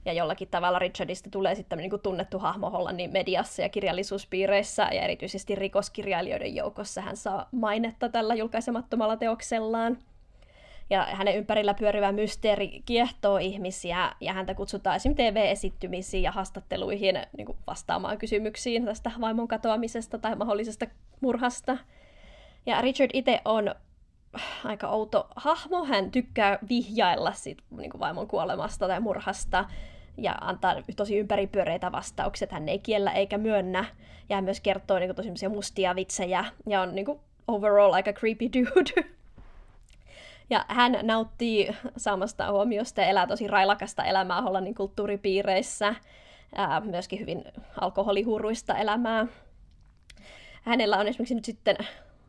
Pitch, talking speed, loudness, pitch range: 205 Hz, 130 wpm, -28 LUFS, 195-230 Hz